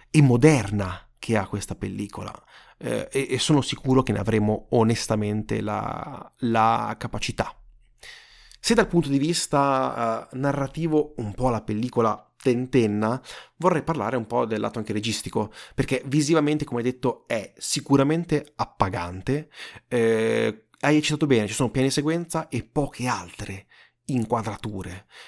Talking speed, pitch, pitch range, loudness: 140 wpm, 125 Hz, 110-145 Hz, -24 LUFS